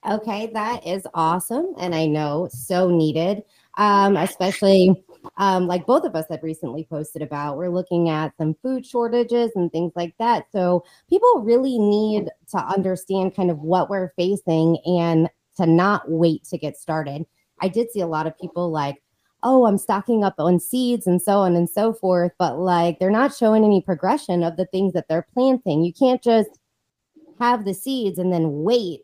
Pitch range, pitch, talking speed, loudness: 165-215 Hz, 185 Hz, 185 wpm, -21 LUFS